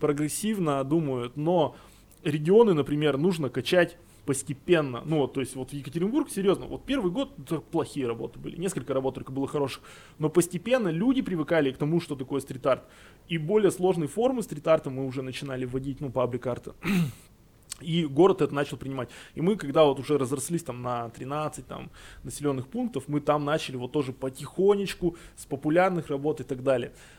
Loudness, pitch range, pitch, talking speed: -27 LUFS, 135-170 Hz, 145 Hz, 165 wpm